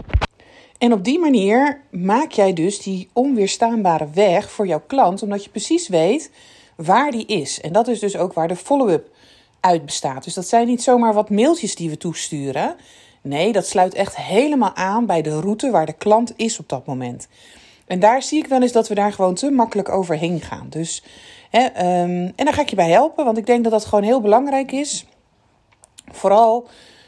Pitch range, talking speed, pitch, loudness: 175-240 Hz, 200 wpm, 210 Hz, -18 LUFS